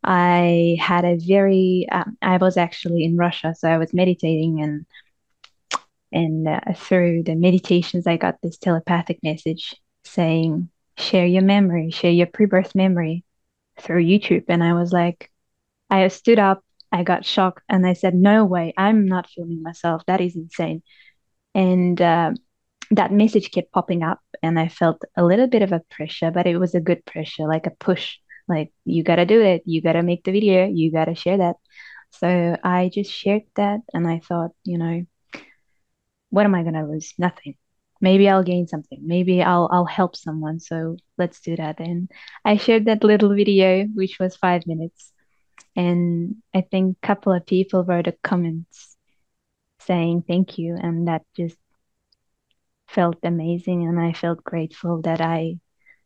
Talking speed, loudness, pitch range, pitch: 170 wpm, -20 LUFS, 165-185 Hz, 175 Hz